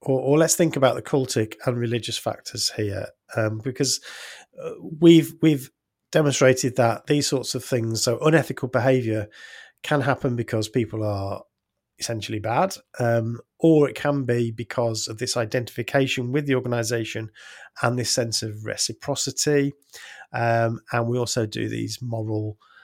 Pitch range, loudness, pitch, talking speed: 115-140 Hz, -23 LUFS, 125 Hz, 145 wpm